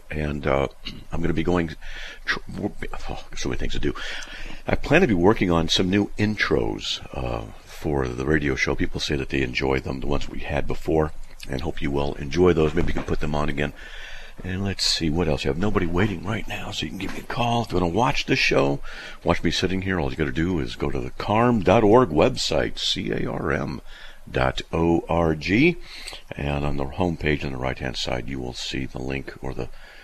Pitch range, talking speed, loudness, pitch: 70-90 Hz, 225 wpm, -24 LUFS, 80 Hz